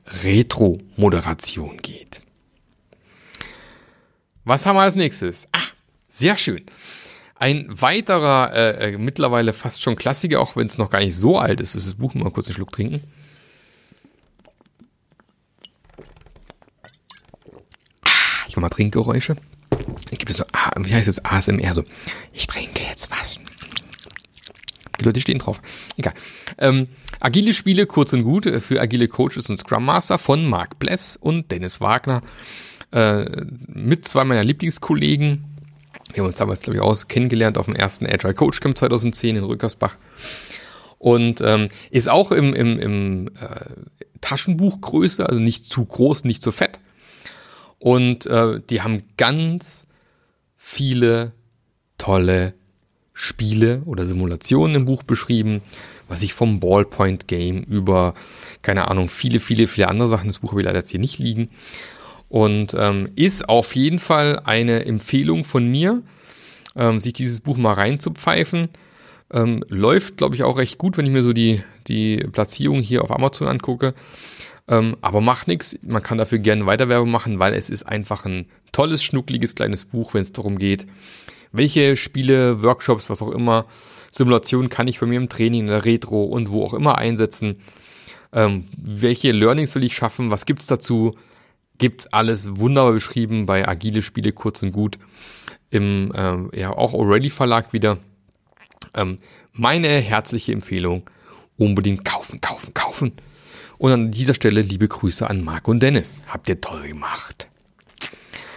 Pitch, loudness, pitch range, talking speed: 115 Hz, -19 LUFS, 105-130 Hz, 150 wpm